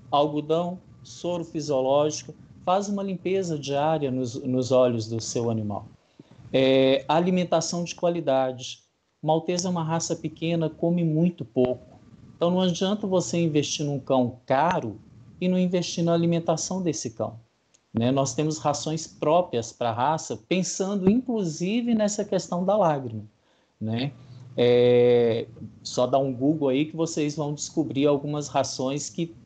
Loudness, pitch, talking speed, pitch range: -25 LUFS, 150 Hz, 140 wpm, 125-170 Hz